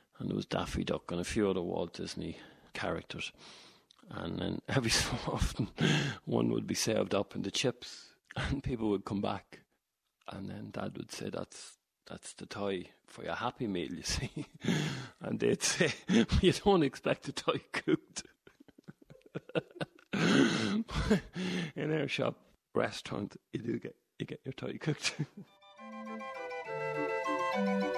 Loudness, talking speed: -34 LUFS, 140 wpm